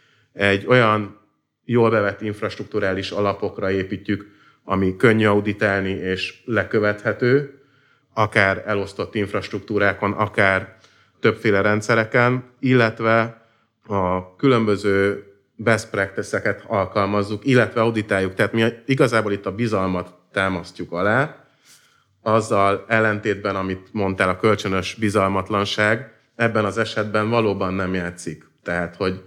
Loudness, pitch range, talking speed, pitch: -20 LUFS, 95-110 Hz, 100 wpm, 105 Hz